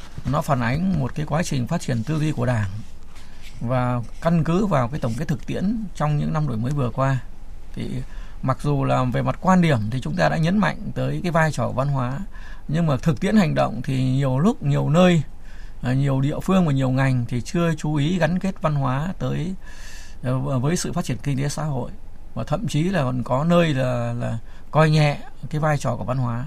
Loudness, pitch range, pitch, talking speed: -22 LUFS, 125-160 Hz, 140 Hz, 230 wpm